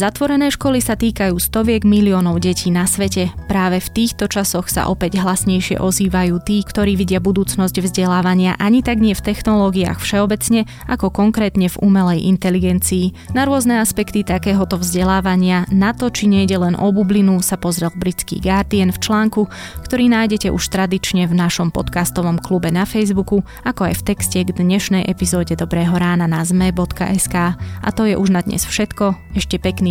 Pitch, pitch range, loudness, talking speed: 190 Hz, 180-205 Hz, -16 LUFS, 165 wpm